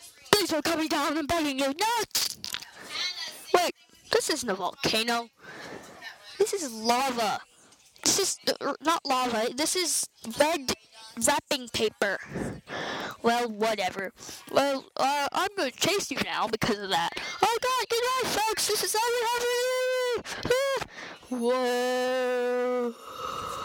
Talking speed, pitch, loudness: 115 wpm, 295 Hz, -27 LUFS